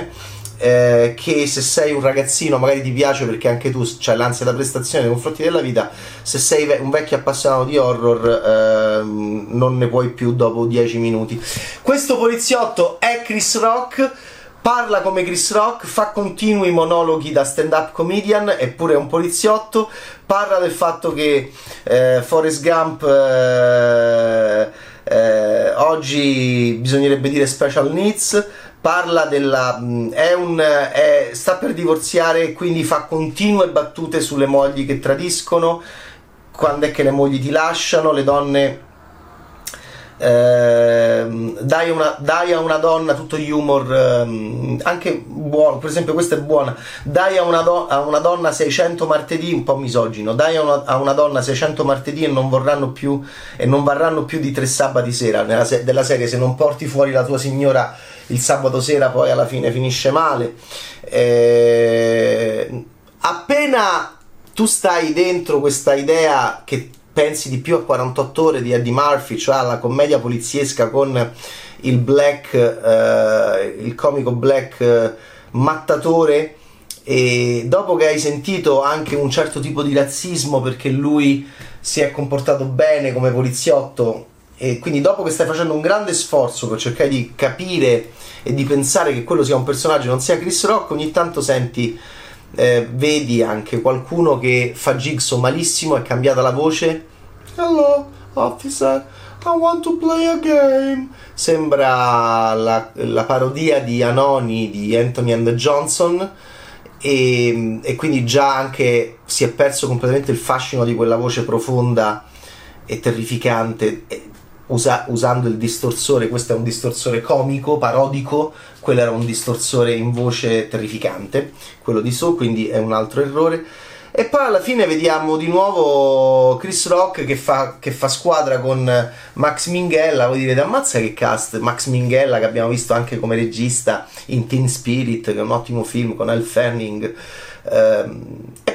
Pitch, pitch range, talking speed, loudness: 135 Hz, 120-160 Hz, 150 wpm, -16 LUFS